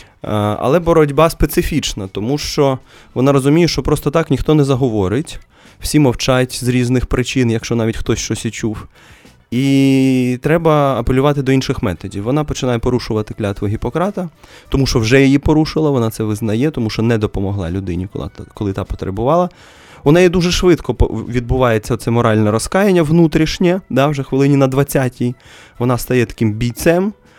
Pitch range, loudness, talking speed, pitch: 115-150 Hz, -15 LUFS, 150 wpm, 130 Hz